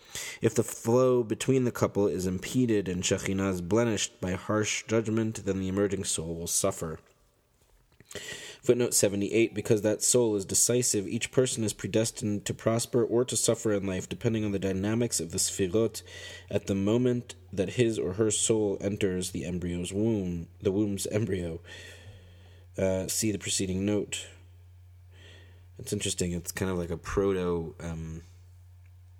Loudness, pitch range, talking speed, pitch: -28 LUFS, 90-110 Hz, 155 wpm, 100 Hz